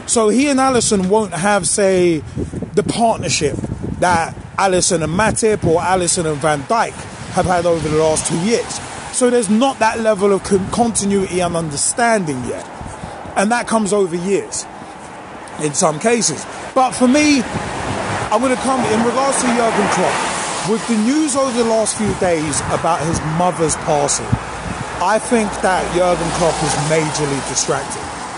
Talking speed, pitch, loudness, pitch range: 160 wpm, 195 Hz, -16 LUFS, 165-225 Hz